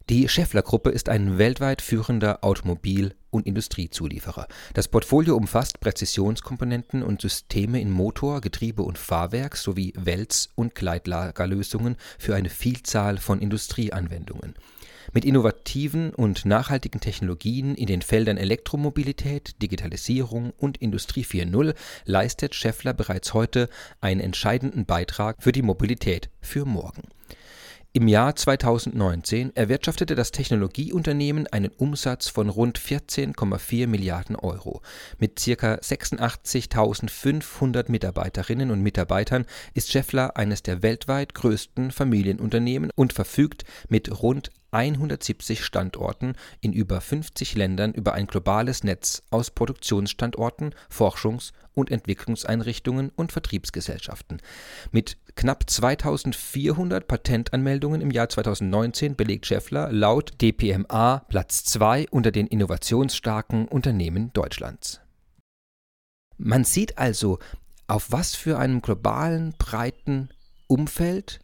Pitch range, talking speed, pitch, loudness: 100-130 Hz, 110 wpm, 115 Hz, -25 LUFS